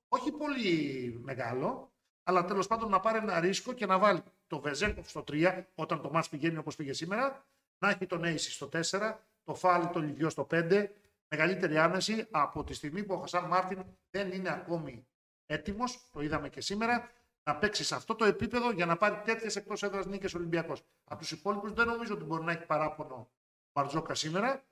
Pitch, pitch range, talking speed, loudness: 180 Hz, 155-210 Hz, 190 wpm, -33 LUFS